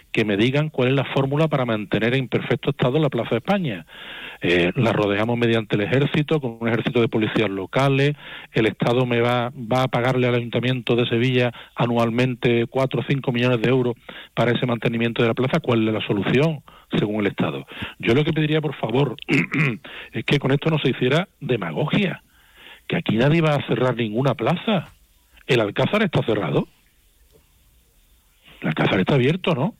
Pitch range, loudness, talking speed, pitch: 115-140 Hz, -21 LUFS, 180 wpm, 125 Hz